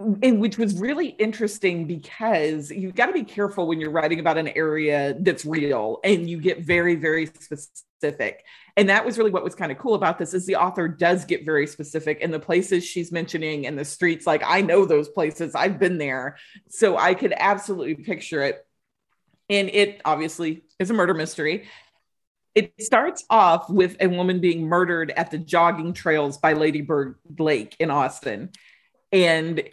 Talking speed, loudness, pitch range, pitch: 185 wpm, -22 LUFS, 155-205 Hz, 175 Hz